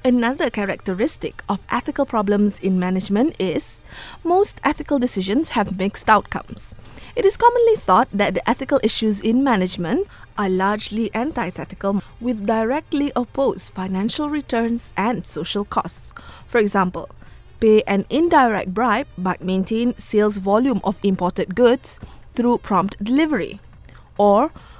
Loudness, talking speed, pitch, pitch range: -20 LUFS, 125 wpm, 220 Hz, 195-260 Hz